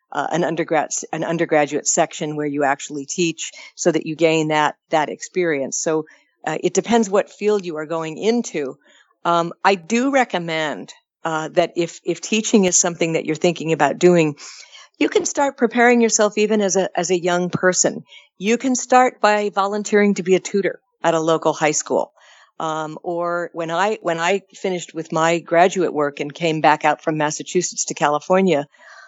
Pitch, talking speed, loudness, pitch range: 175 Hz, 180 wpm, -19 LUFS, 160-200 Hz